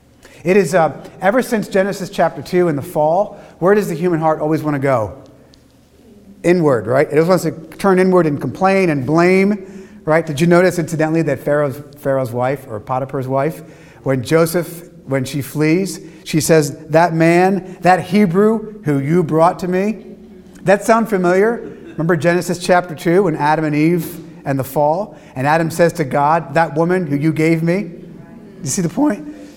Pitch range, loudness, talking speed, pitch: 150-185 Hz, -16 LUFS, 180 wpm, 170 Hz